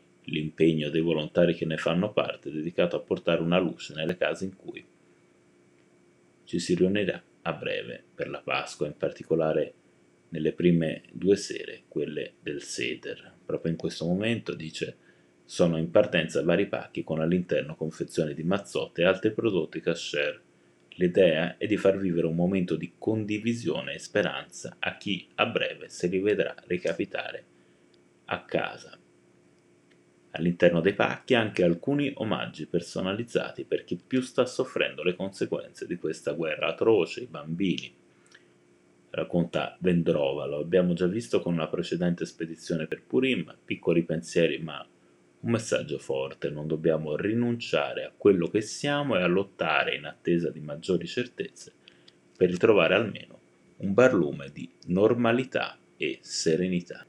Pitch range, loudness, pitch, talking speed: 80-105 Hz, -28 LUFS, 85 Hz, 140 wpm